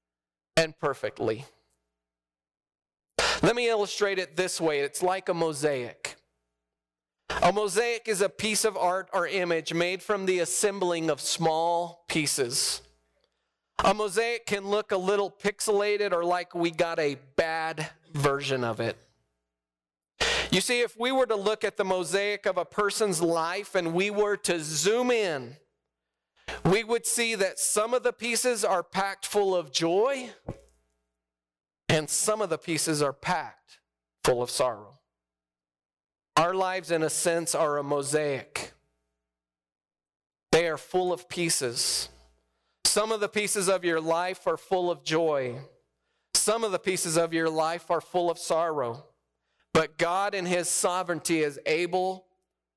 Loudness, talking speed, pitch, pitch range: -27 LUFS, 145 wpm, 170 Hz, 125-200 Hz